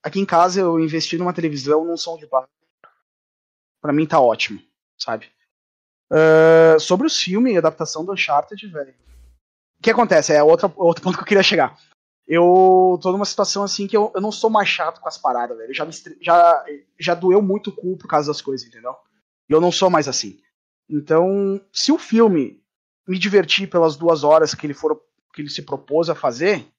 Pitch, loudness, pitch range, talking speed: 170 Hz, -17 LUFS, 150-195 Hz, 195 wpm